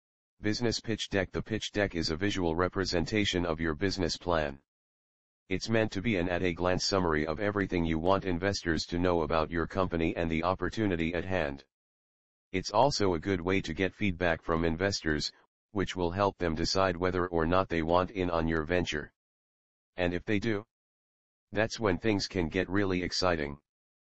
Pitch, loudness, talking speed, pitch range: 90 Hz, -31 LUFS, 175 wpm, 80-95 Hz